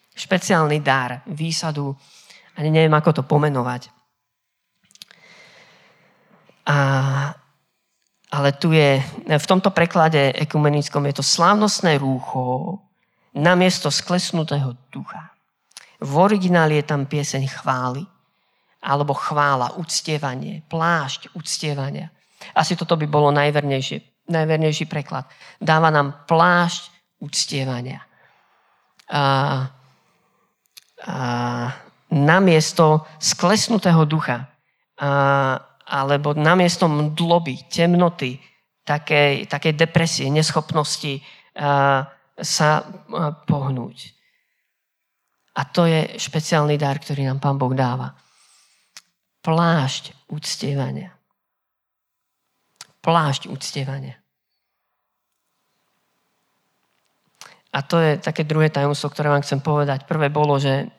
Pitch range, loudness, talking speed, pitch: 140-165 Hz, -20 LUFS, 90 wpm, 150 Hz